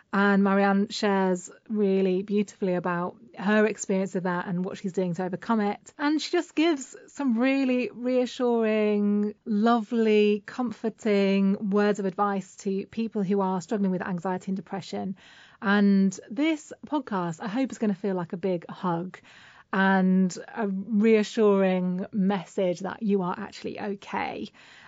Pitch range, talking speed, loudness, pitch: 190-225 Hz, 145 wpm, -26 LUFS, 200 Hz